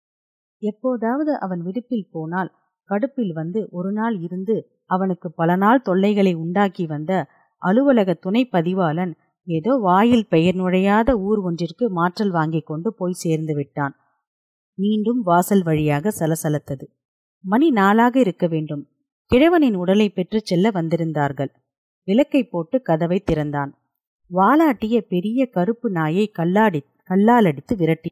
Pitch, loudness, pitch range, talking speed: 185 Hz, -20 LUFS, 165-220 Hz, 115 wpm